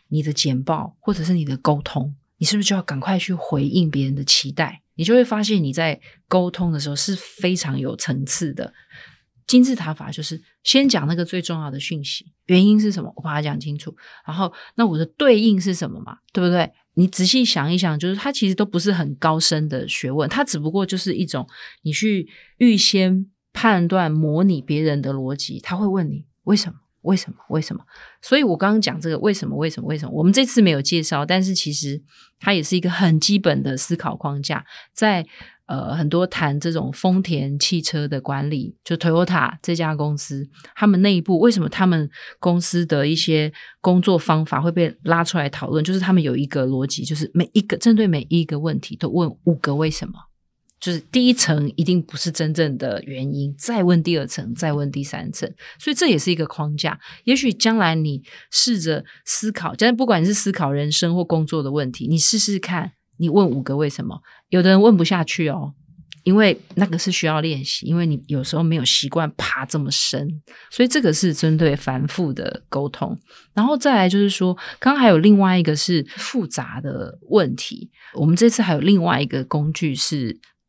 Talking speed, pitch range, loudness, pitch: 300 characters per minute, 150-190 Hz, -19 LUFS, 165 Hz